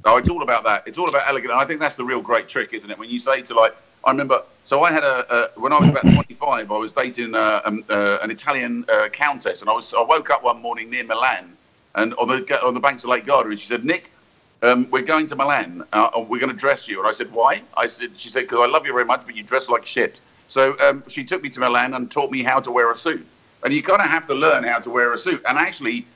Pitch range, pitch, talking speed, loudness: 120-165 Hz, 135 Hz, 295 wpm, -19 LUFS